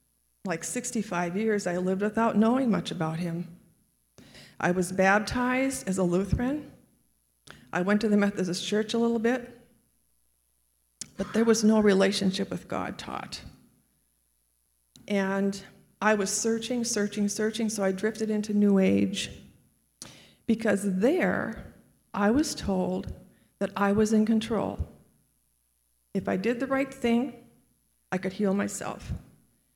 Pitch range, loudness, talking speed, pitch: 175-225 Hz, -27 LUFS, 130 wpm, 200 Hz